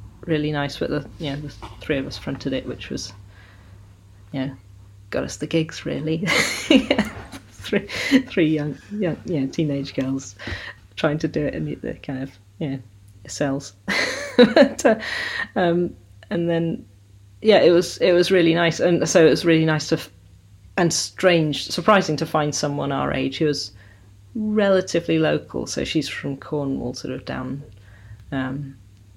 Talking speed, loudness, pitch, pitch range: 160 wpm, -21 LUFS, 145 Hz, 100-170 Hz